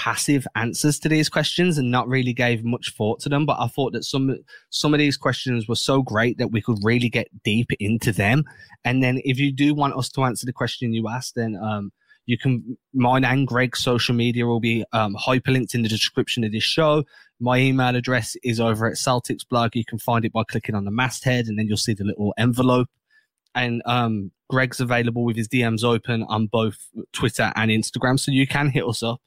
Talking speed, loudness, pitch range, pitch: 220 wpm, -22 LUFS, 115-130 Hz, 120 Hz